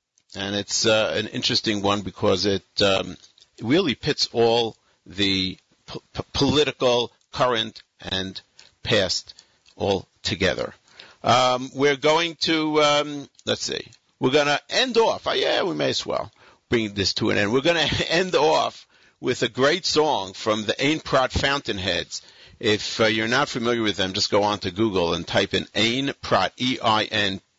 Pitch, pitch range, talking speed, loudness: 115 Hz, 100-135 Hz, 170 wpm, -22 LUFS